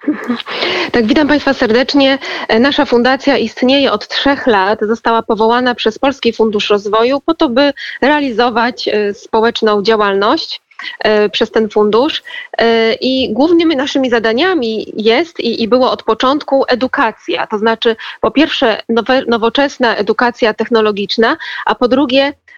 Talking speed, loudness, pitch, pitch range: 120 wpm, -12 LUFS, 245 Hz, 225-280 Hz